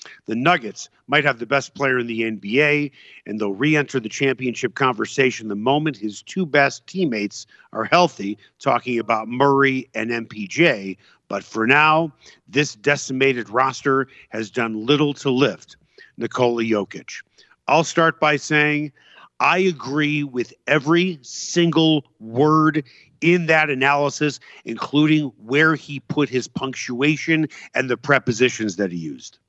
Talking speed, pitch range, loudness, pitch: 140 wpm, 120-150 Hz, -20 LUFS, 140 Hz